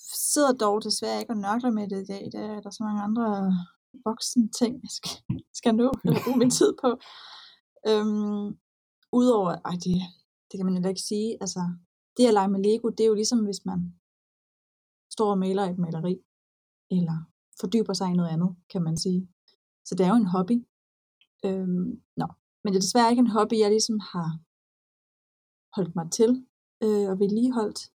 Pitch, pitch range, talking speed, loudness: 205 Hz, 185-225 Hz, 185 wpm, -26 LUFS